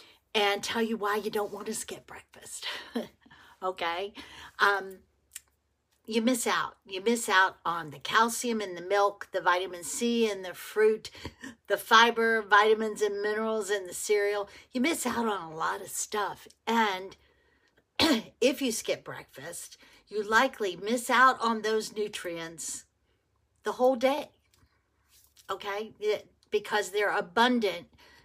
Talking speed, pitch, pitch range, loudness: 140 wpm, 215 Hz, 195-235 Hz, -28 LUFS